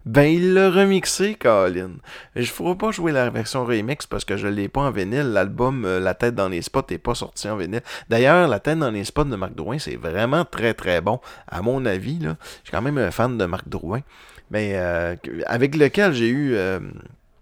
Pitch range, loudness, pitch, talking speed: 100-150 Hz, -21 LUFS, 120 Hz, 225 wpm